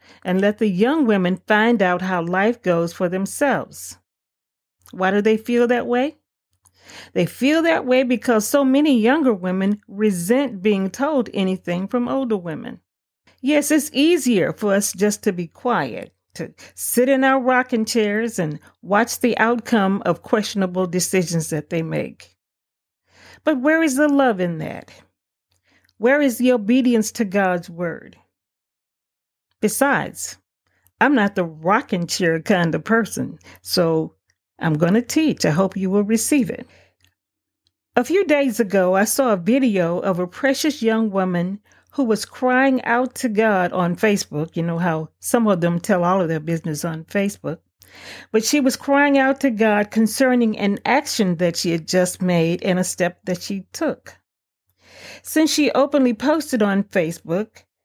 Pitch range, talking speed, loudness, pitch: 180-250 Hz, 160 wpm, -19 LUFS, 210 Hz